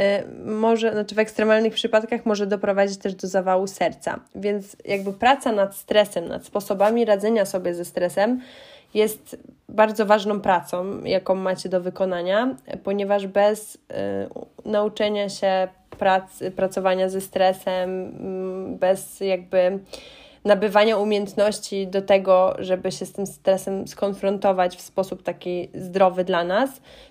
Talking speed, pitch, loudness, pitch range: 125 wpm, 195 Hz, -22 LUFS, 185-210 Hz